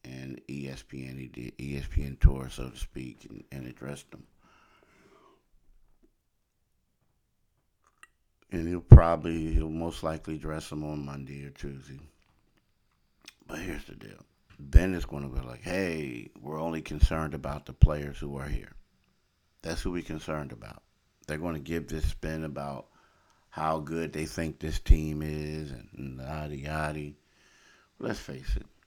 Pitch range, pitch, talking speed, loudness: 70-80 Hz, 75 Hz, 145 wpm, -30 LUFS